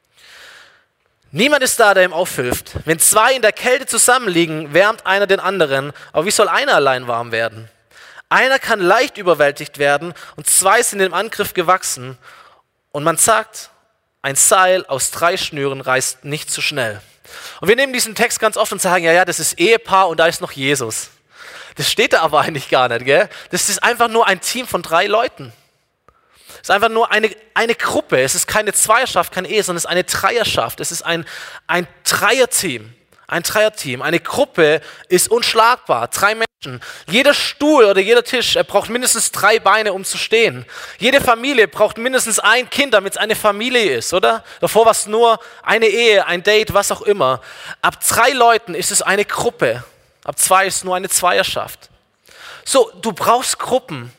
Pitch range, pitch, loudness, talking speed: 165-230 Hz, 195 Hz, -15 LUFS, 185 wpm